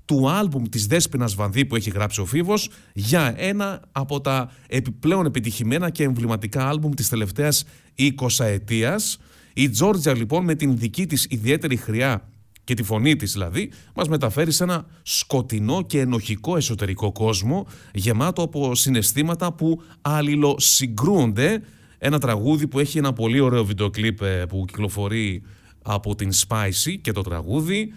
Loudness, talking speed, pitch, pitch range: -22 LUFS, 145 wpm, 130 Hz, 110-150 Hz